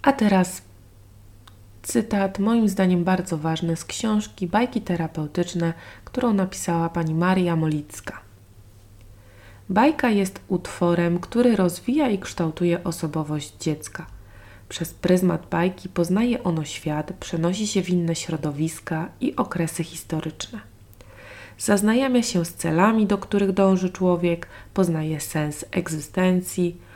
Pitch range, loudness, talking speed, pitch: 155-190 Hz, -23 LUFS, 110 wpm, 170 Hz